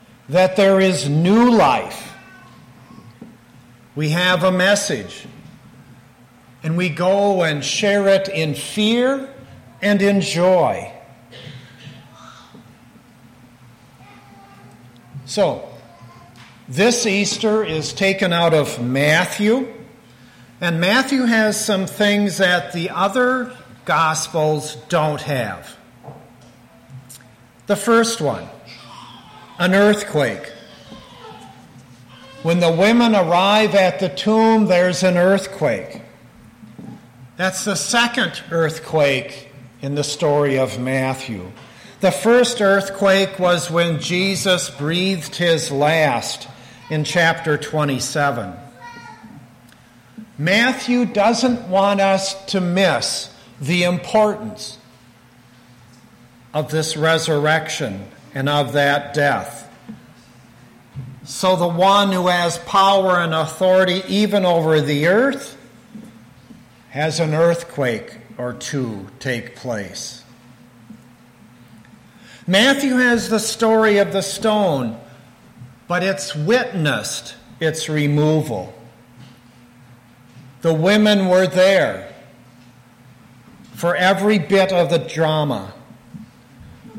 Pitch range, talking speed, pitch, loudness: 125-195 Hz, 90 wpm, 160 Hz, -17 LUFS